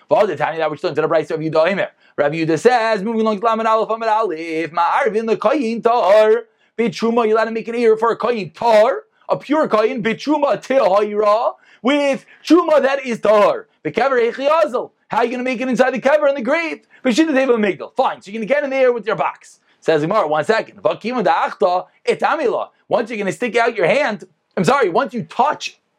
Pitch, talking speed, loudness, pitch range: 225 Hz, 235 wpm, -17 LUFS, 205-265 Hz